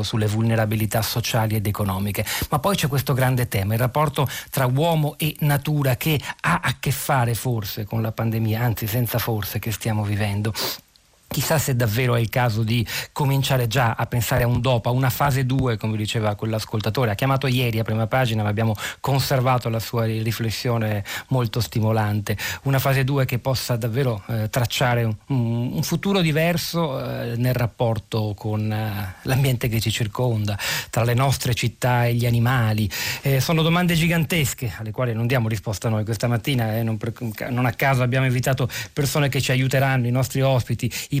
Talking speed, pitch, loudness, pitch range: 180 wpm, 120 Hz, -22 LUFS, 110-135 Hz